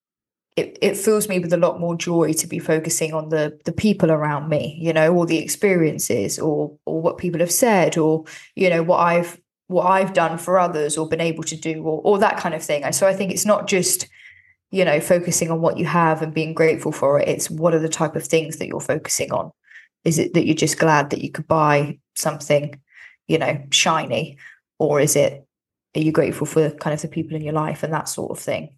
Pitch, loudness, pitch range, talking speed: 160 Hz, -20 LUFS, 155-175 Hz, 235 wpm